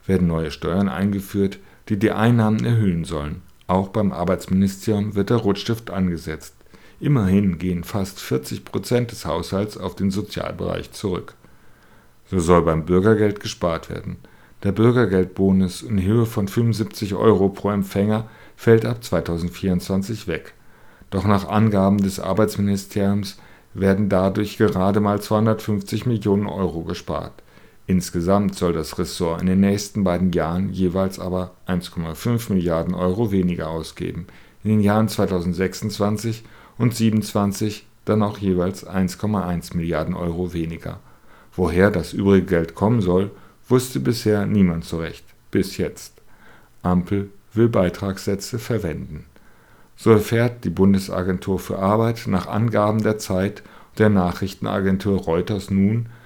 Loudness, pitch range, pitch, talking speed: -21 LUFS, 90-105 Hz, 95 Hz, 125 wpm